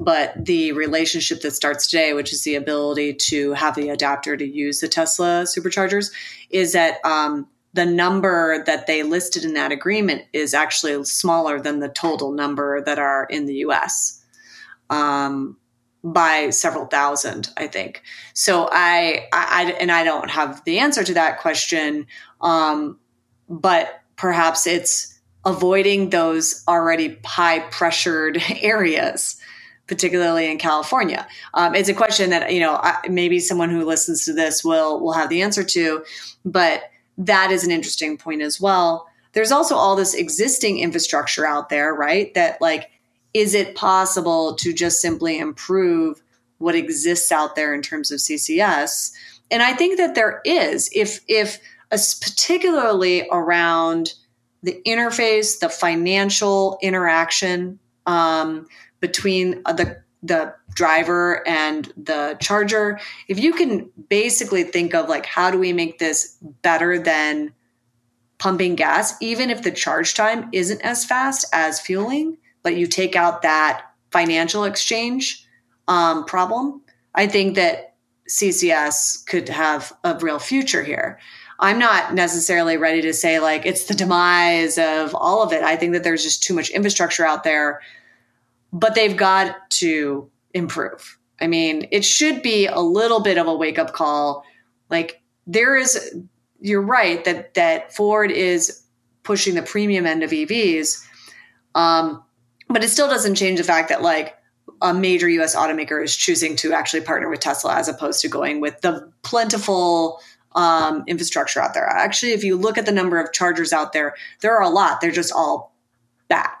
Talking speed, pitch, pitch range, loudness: 155 wpm, 175 Hz, 155-205 Hz, -19 LUFS